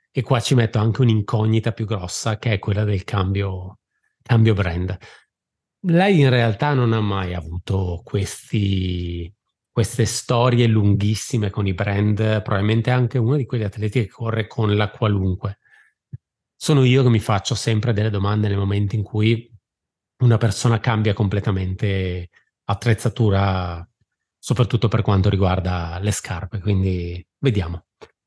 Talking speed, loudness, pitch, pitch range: 140 wpm, -20 LUFS, 105 Hz, 100-115 Hz